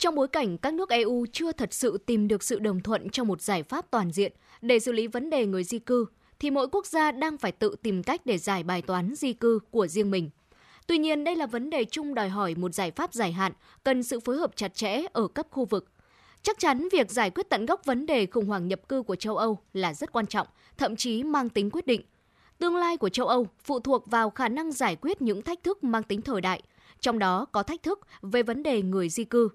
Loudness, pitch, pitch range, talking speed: -28 LUFS, 235 Hz, 205-285 Hz, 255 wpm